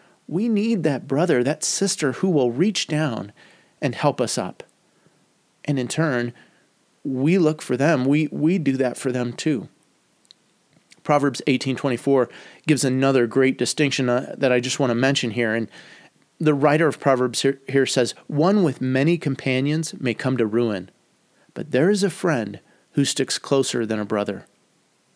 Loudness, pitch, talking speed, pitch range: -21 LUFS, 135 Hz, 165 wpm, 125-155 Hz